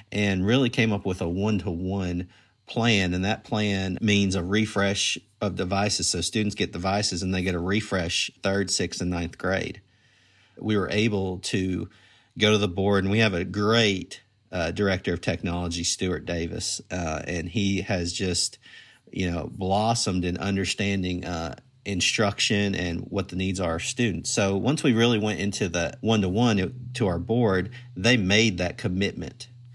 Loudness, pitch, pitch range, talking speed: -25 LUFS, 100 Hz, 90-105 Hz, 165 wpm